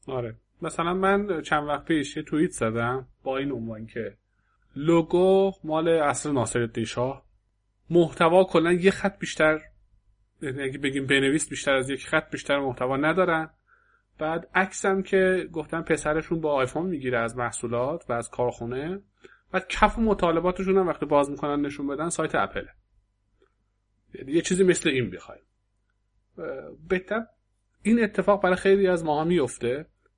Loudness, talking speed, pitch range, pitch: -25 LUFS, 140 wpm, 120-175 Hz, 150 Hz